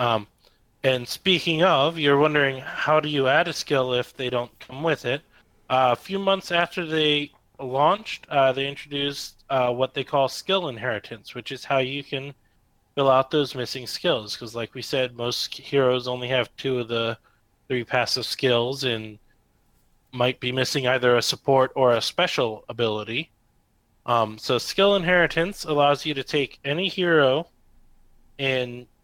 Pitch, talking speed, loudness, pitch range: 130 Hz, 165 wpm, -23 LUFS, 120-145 Hz